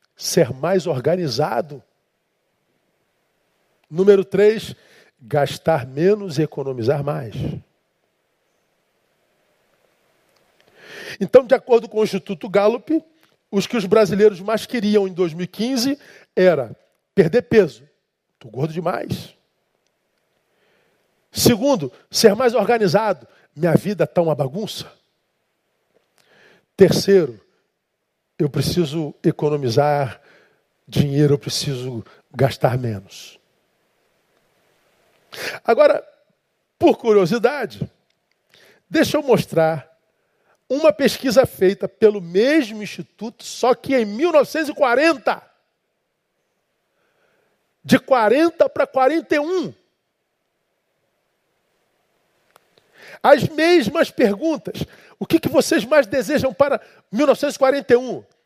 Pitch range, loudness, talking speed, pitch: 160-265 Hz, -18 LUFS, 80 wpm, 205 Hz